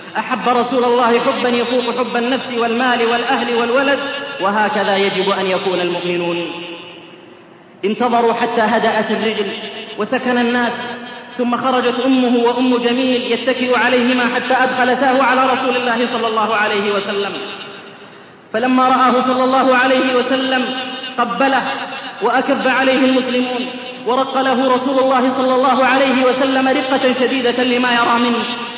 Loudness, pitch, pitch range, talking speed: -15 LUFS, 245 Hz, 225-255 Hz, 125 wpm